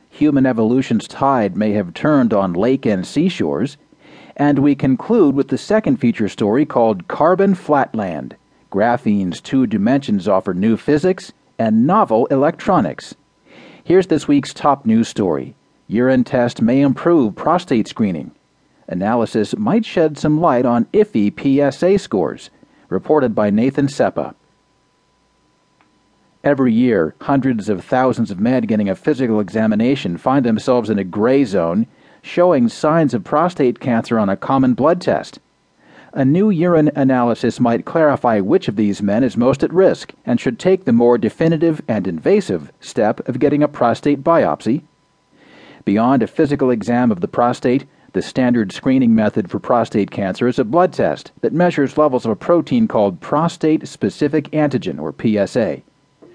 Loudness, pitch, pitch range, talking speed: -16 LUFS, 135 Hz, 115-155 Hz, 150 wpm